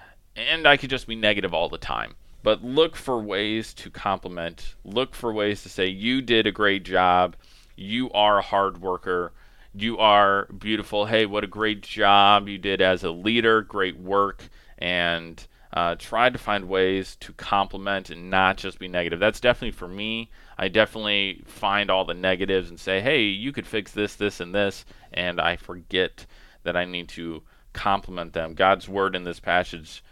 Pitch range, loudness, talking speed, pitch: 90-105 Hz, -23 LUFS, 185 wpm, 100 Hz